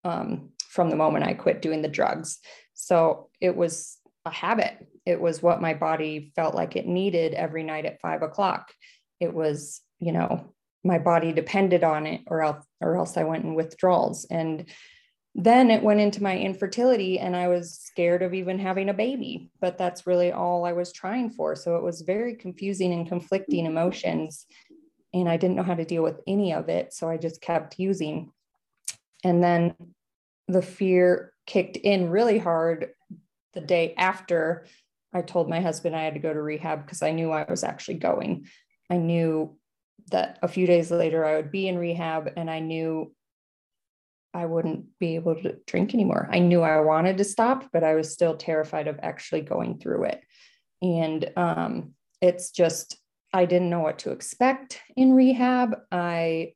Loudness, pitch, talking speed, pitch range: -25 LUFS, 175 Hz, 180 wpm, 165-190 Hz